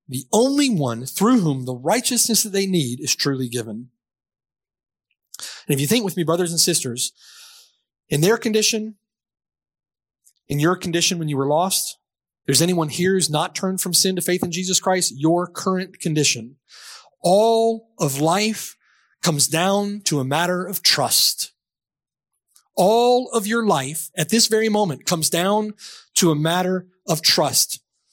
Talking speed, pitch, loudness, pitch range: 155 wpm, 180 Hz, -19 LUFS, 150-210 Hz